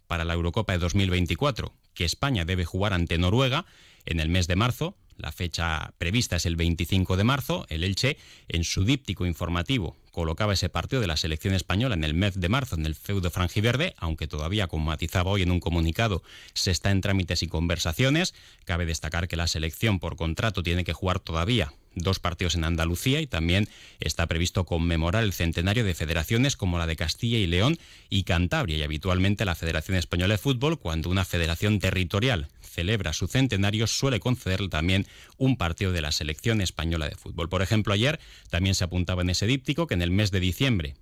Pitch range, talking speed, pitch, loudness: 85-105 Hz, 195 wpm, 90 Hz, -26 LUFS